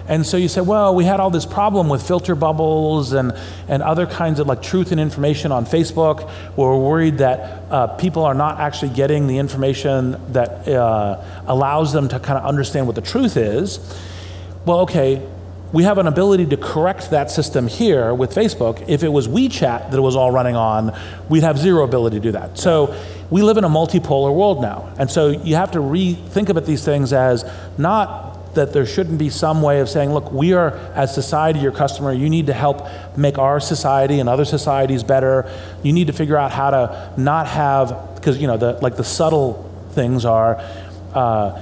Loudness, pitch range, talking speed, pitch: -17 LUFS, 125-160 Hz, 205 wpm, 140 Hz